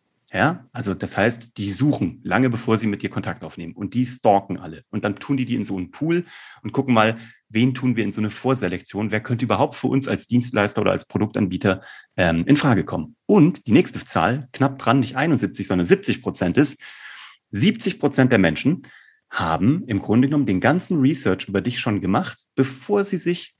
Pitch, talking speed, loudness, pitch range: 120 Hz, 205 wpm, -21 LUFS, 100-135 Hz